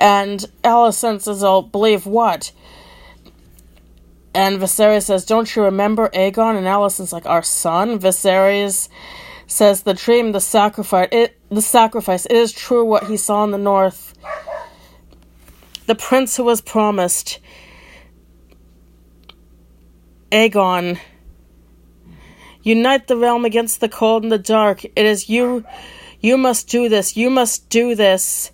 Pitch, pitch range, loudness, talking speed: 205 Hz, 180-230 Hz, -16 LUFS, 130 wpm